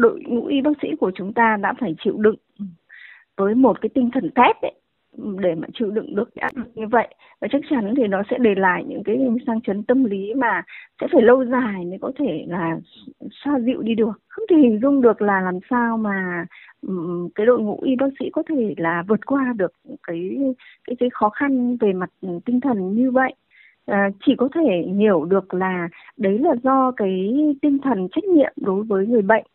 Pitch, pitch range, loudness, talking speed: 230 Hz, 195-265 Hz, -20 LUFS, 210 wpm